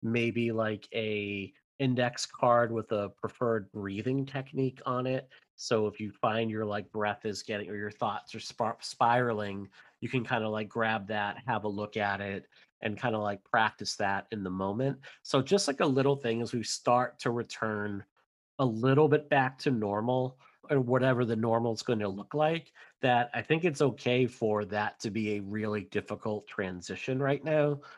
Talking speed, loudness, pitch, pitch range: 190 wpm, -31 LUFS, 115 Hz, 105-130 Hz